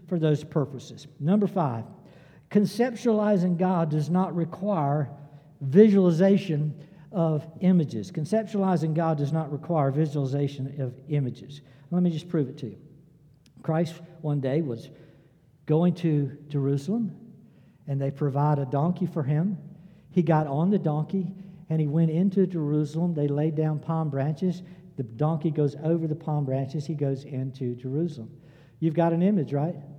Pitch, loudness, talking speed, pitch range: 155 Hz, -26 LUFS, 145 wpm, 145-175 Hz